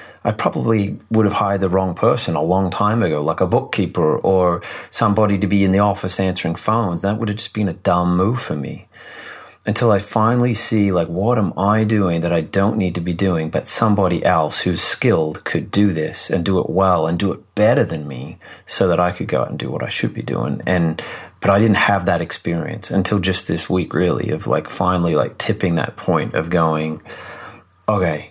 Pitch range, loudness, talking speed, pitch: 90-105 Hz, -18 LUFS, 220 wpm, 95 Hz